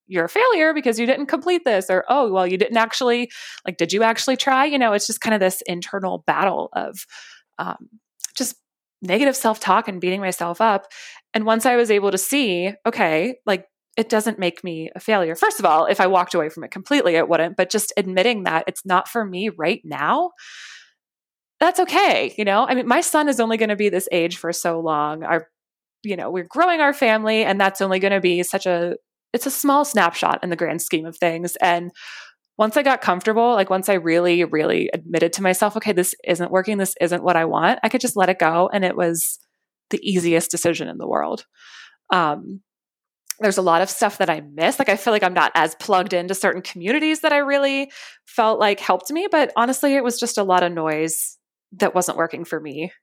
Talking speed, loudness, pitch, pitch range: 220 wpm, -19 LUFS, 200 Hz, 175-240 Hz